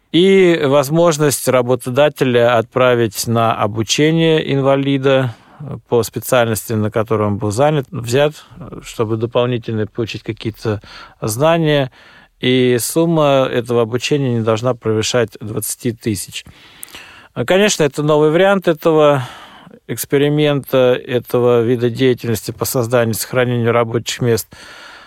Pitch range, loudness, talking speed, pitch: 115-145 Hz, -15 LUFS, 105 wpm, 125 Hz